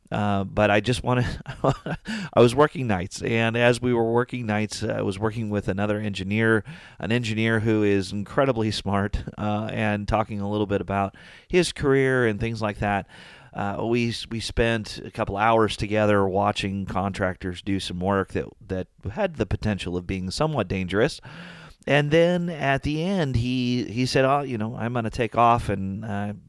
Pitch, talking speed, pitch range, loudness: 110 Hz, 185 wpm, 100-120 Hz, -24 LUFS